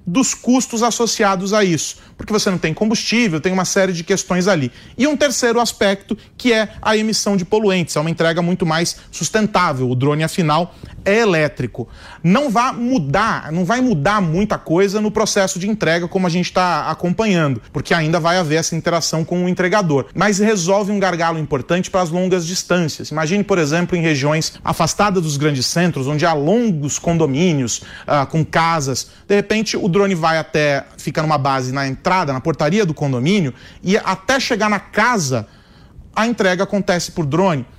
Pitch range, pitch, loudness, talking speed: 160-205 Hz, 180 Hz, -17 LUFS, 180 wpm